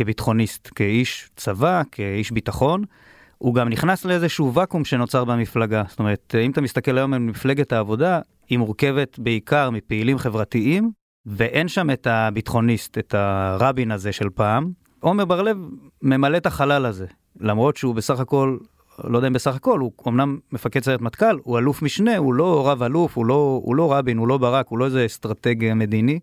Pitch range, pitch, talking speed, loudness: 115-140 Hz, 125 Hz, 175 wpm, -21 LUFS